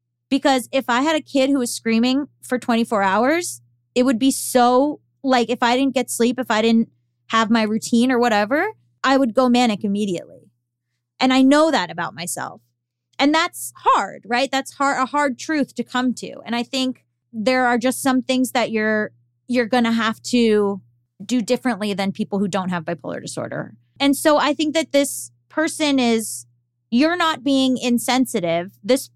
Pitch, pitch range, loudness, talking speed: 245 Hz, 200-265 Hz, -19 LUFS, 185 wpm